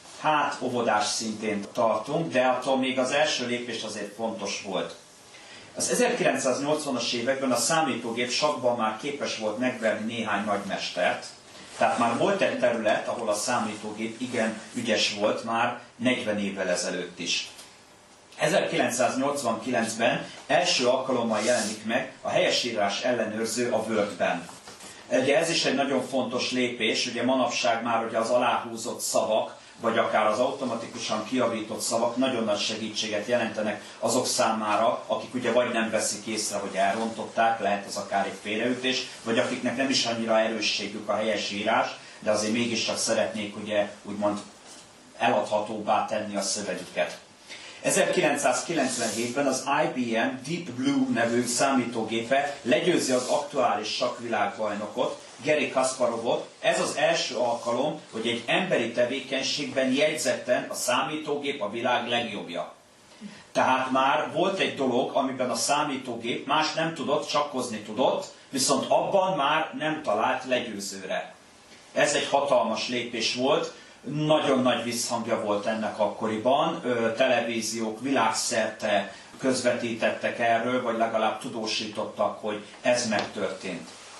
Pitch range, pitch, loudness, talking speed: 110-130 Hz, 120 Hz, -26 LUFS, 125 wpm